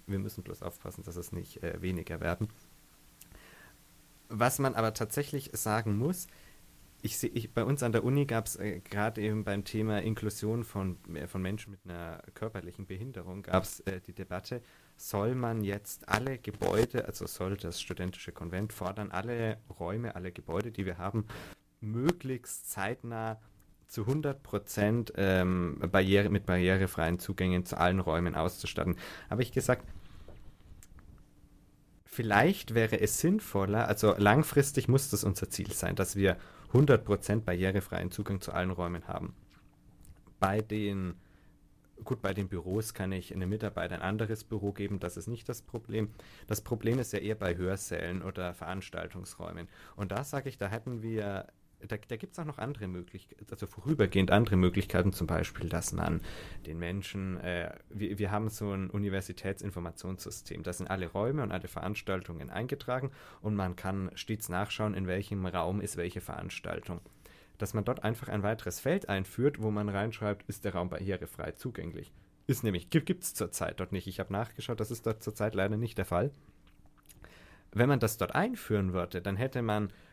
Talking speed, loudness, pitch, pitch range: 165 wpm, -33 LUFS, 100 Hz, 90-110 Hz